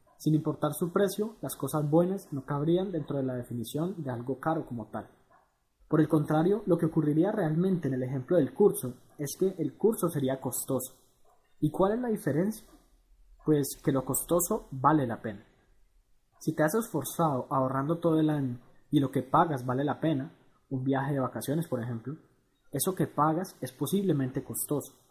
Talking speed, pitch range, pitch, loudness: 180 wpm, 130-165 Hz, 145 Hz, -30 LUFS